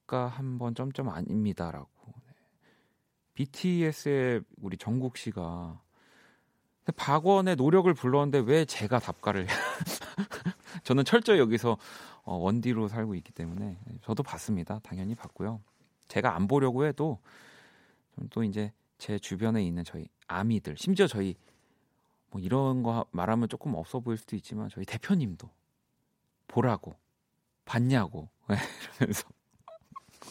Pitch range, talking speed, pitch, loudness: 100-140 Hz, 255 characters per minute, 115 Hz, -30 LUFS